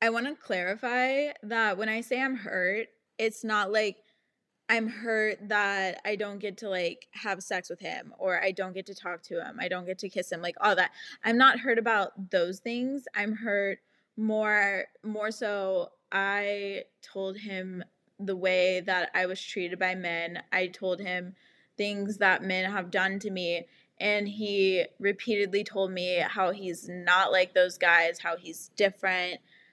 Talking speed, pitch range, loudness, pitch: 180 wpm, 185-215 Hz, -29 LUFS, 200 Hz